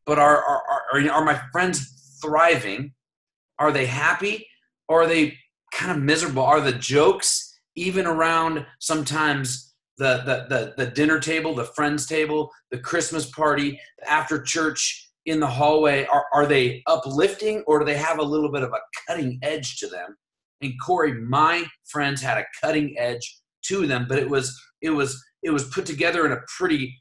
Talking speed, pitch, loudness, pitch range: 175 wpm, 150 Hz, -22 LUFS, 135-160 Hz